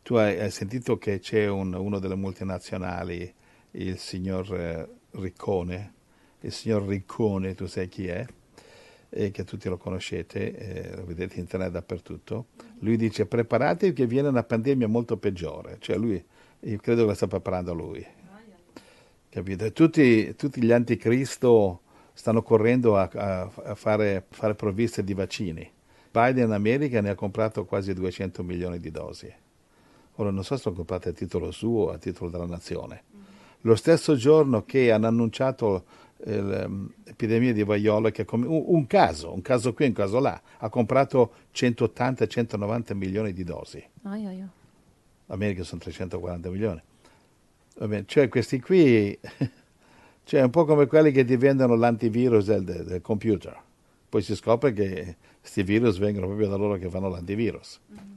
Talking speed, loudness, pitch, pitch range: 150 wpm, -25 LUFS, 105 Hz, 95-120 Hz